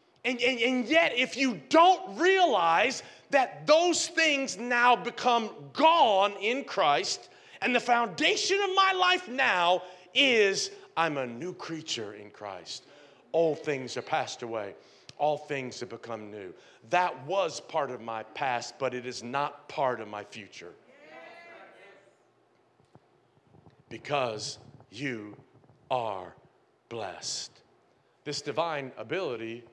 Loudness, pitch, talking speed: -27 LUFS, 180 Hz, 125 wpm